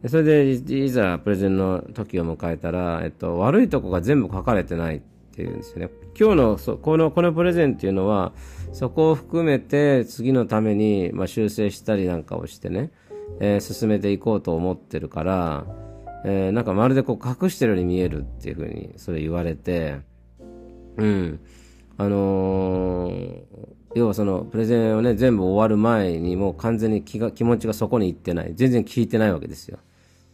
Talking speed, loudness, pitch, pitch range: 350 characters per minute, -22 LUFS, 100 Hz, 90-120 Hz